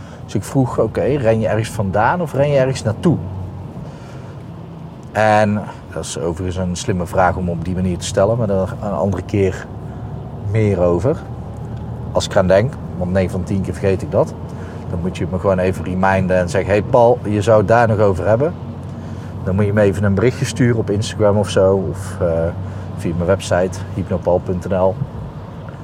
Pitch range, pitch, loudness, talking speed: 95-115 Hz, 100 Hz, -17 LUFS, 190 wpm